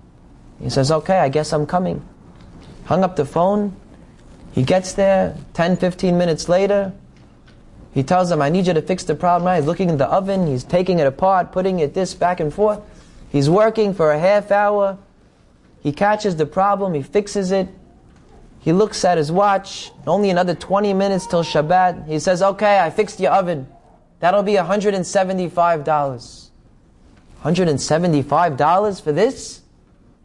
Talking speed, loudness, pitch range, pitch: 160 wpm, -18 LUFS, 155-195 Hz, 180 Hz